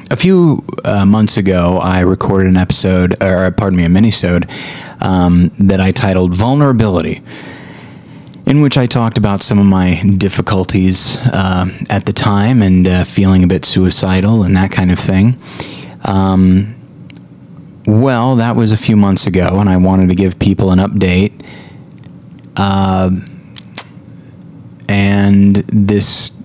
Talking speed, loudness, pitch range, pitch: 140 wpm, -11 LUFS, 95-110 Hz, 95 Hz